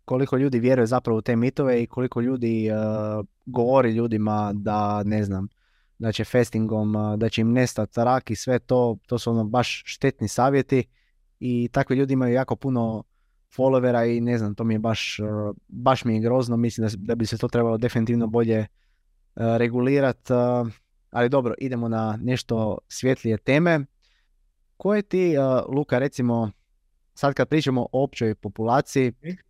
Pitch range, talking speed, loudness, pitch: 110-130 Hz, 170 wpm, -23 LUFS, 120 Hz